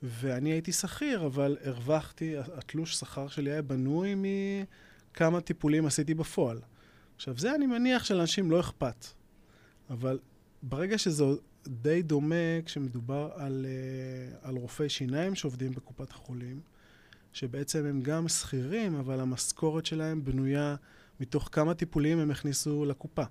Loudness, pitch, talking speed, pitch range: -32 LUFS, 145 Hz, 125 wpm, 130-160 Hz